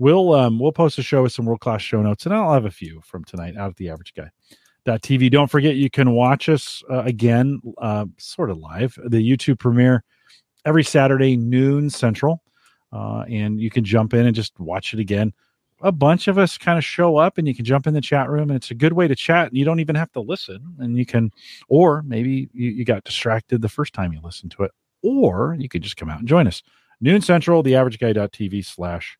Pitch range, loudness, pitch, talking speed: 110-150 Hz, -19 LUFS, 125 Hz, 230 wpm